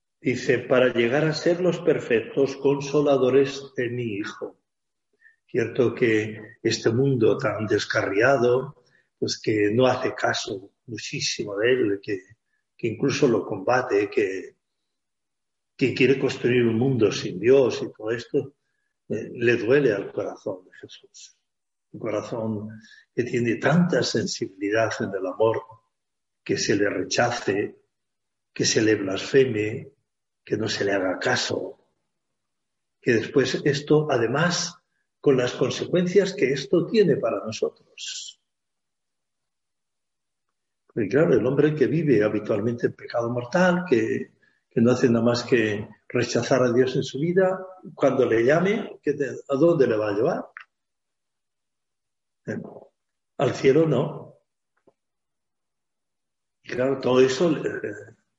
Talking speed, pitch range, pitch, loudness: 125 wpm, 120-175 Hz, 135 Hz, -23 LUFS